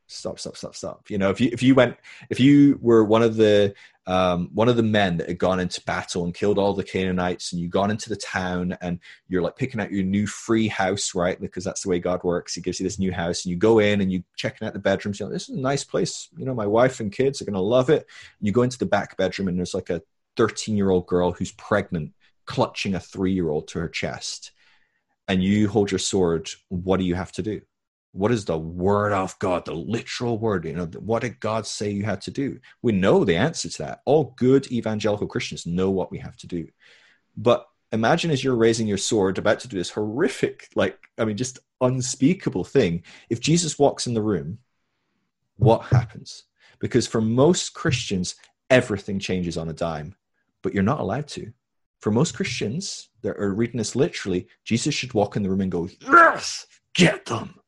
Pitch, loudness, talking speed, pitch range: 105 Hz, -23 LUFS, 225 wpm, 90-115 Hz